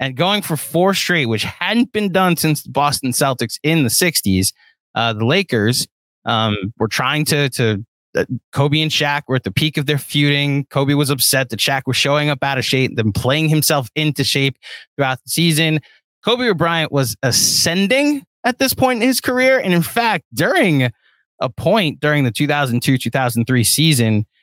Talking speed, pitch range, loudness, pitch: 180 wpm, 125-165 Hz, -16 LUFS, 145 Hz